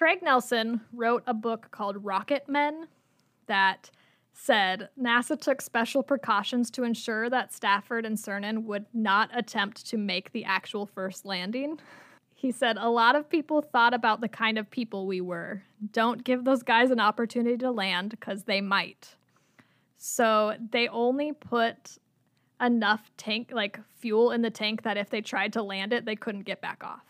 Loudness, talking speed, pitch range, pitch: -28 LUFS, 170 wpm, 205-245 Hz, 230 Hz